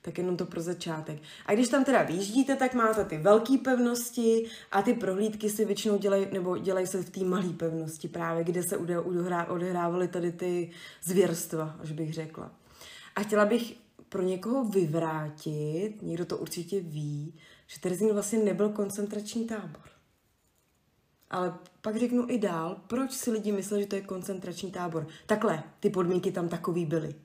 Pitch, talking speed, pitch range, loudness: 185 Hz, 165 wpm, 170-210 Hz, -30 LUFS